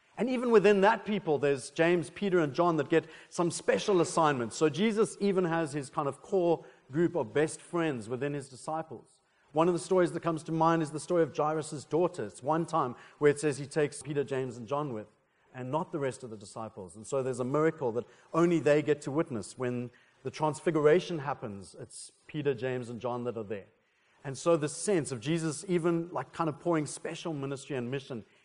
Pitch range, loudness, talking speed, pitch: 130-165 Hz, -30 LUFS, 215 wpm, 150 Hz